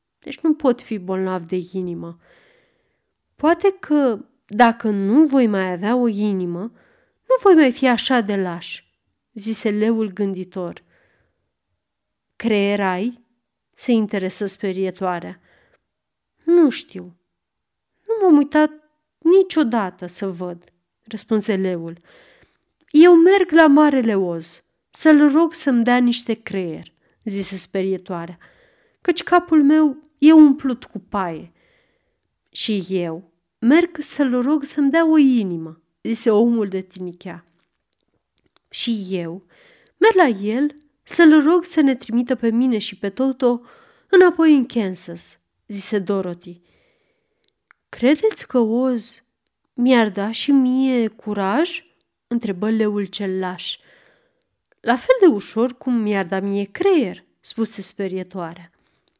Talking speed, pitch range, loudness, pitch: 120 wpm, 190-305 Hz, -18 LUFS, 235 Hz